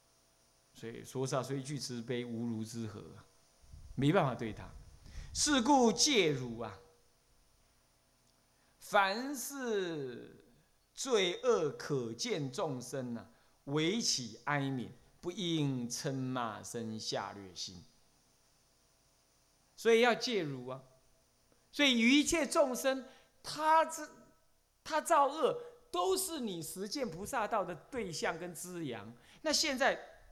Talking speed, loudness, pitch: 155 characters per minute, -34 LUFS, 130 Hz